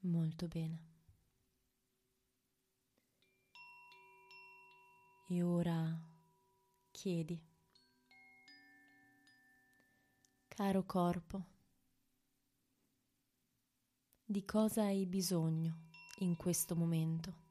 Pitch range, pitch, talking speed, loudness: 130-195 Hz, 165 Hz, 50 wpm, -39 LUFS